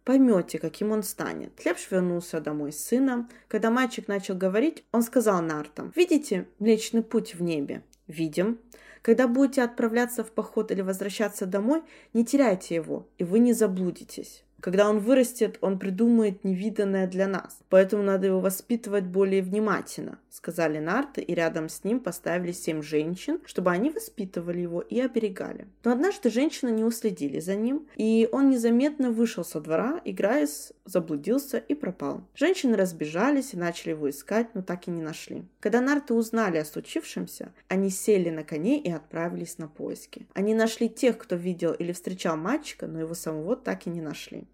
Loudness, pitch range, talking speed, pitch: -27 LUFS, 175-235 Hz, 165 wpm, 210 Hz